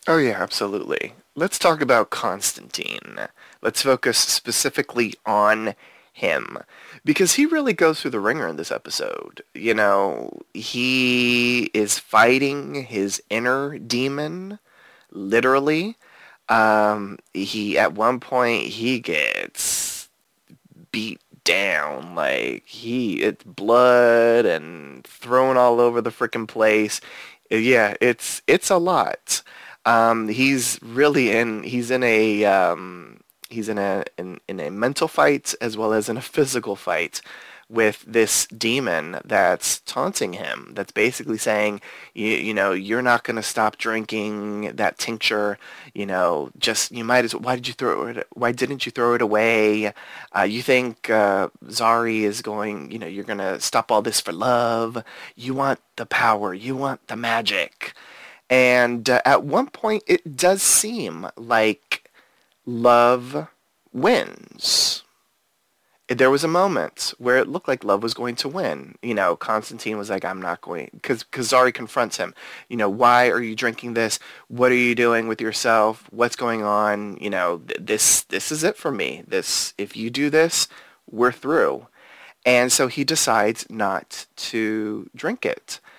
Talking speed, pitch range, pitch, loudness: 150 wpm, 110-125 Hz, 120 Hz, -21 LUFS